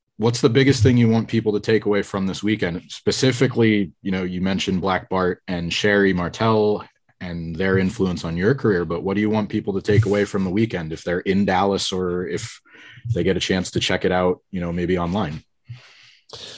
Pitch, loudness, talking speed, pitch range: 100 Hz, -21 LUFS, 215 wpm, 90-110 Hz